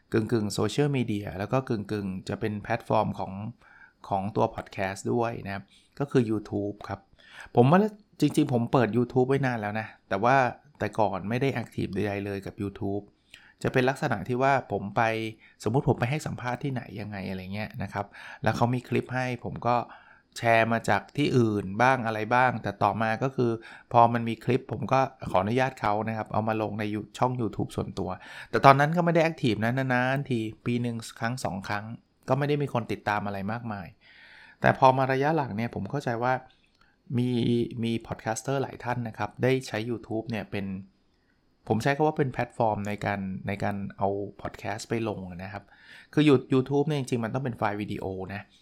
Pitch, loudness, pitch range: 115 Hz, -28 LUFS, 105-130 Hz